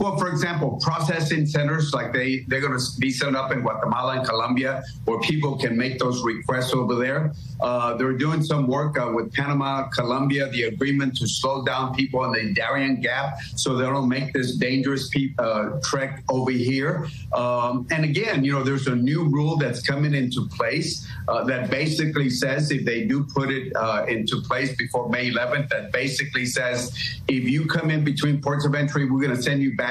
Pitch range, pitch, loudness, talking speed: 125-145 Hz, 135 Hz, -23 LUFS, 200 wpm